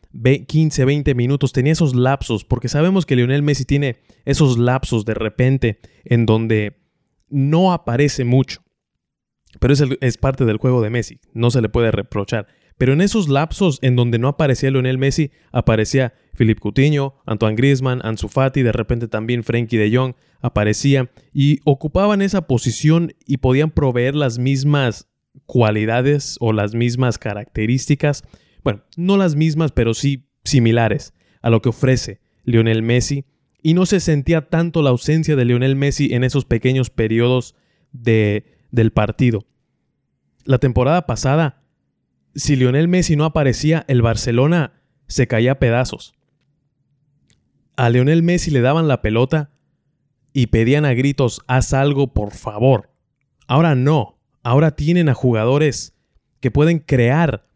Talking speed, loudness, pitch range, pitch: 145 wpm, -17 LUFS, 120-145 Hz, 130 Hz